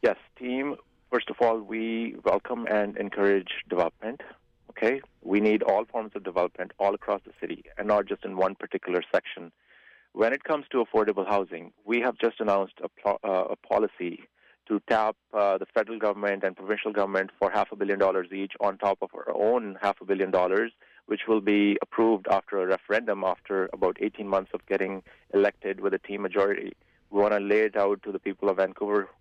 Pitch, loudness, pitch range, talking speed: 100 Hz, -27 LUFS, 95-110 Hz, 195 wpm